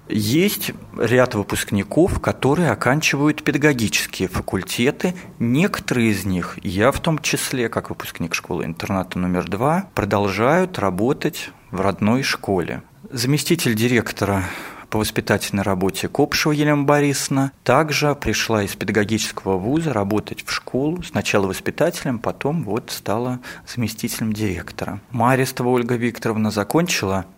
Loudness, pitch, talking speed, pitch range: -20 LUFS, 115 Hz, 110 wpm, 100-145 Hz